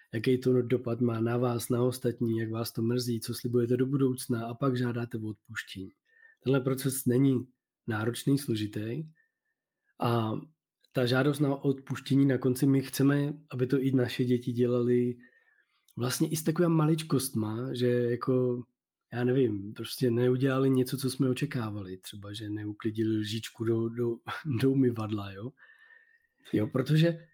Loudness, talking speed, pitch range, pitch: -30 LUFS, 145 wpm, 115-135 Hz, 125 Hz